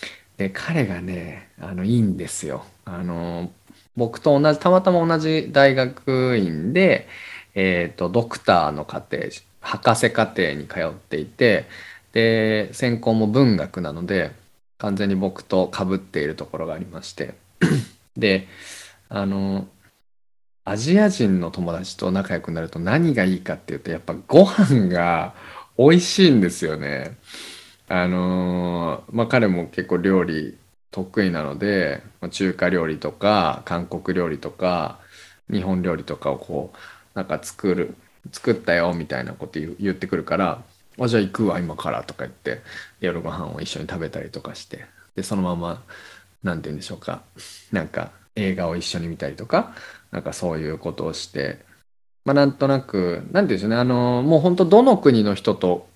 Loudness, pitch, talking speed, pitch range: -21 LUFS, 95 Hz, 300 characters per minute, 90-120 Hz